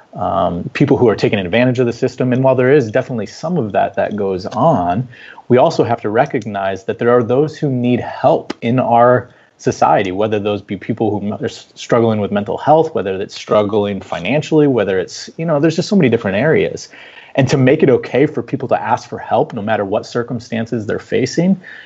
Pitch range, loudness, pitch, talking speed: 105-135 Hz, -15 LUFS, 120 Hz, 210 wpm